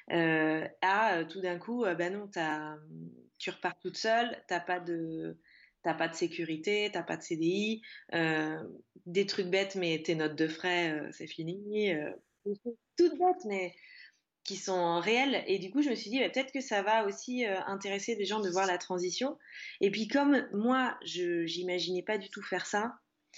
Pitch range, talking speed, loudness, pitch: 170-220 Hz, 185 wpm, -32 LUFS, 185 Hz